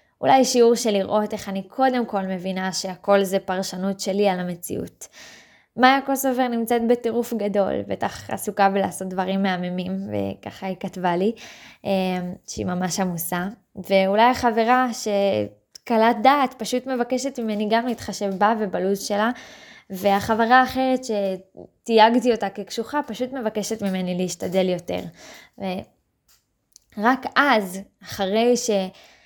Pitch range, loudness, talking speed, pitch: 190-235 Hz, -22 LUFS, 120 wpm, 205 Hz